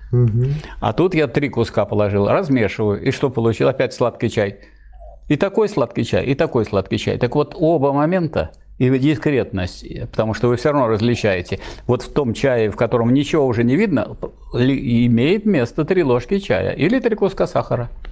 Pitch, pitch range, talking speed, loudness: 125 Hz, 115-150 Hz, 170 wpm, -18 LUFS